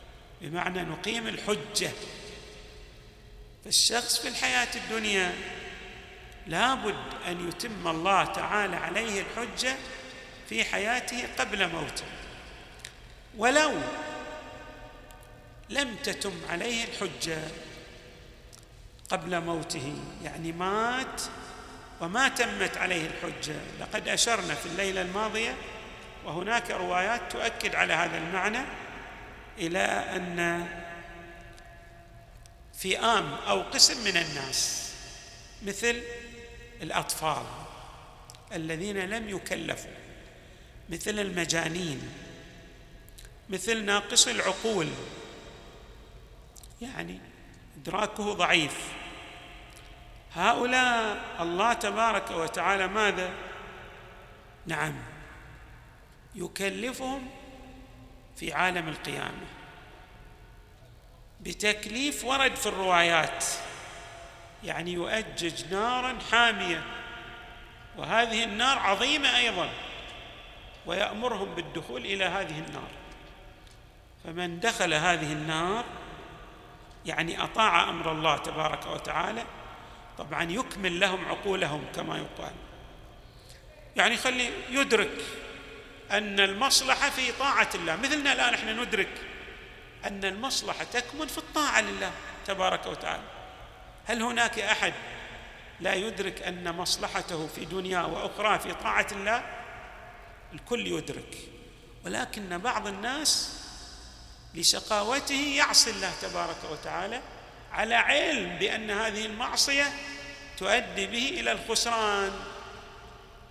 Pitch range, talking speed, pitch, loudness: 170-235 Hz, 85 wpm, 195 Hz, -28 LUFS